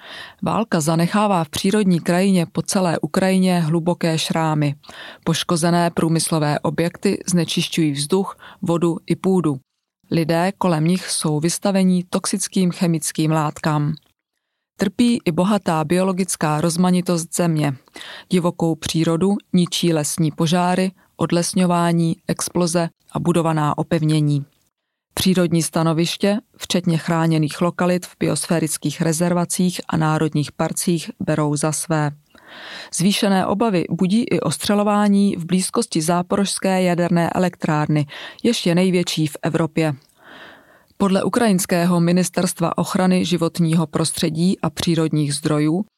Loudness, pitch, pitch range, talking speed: -19 LUFS, 170 Hz, 160-185 Hz, 105 wpm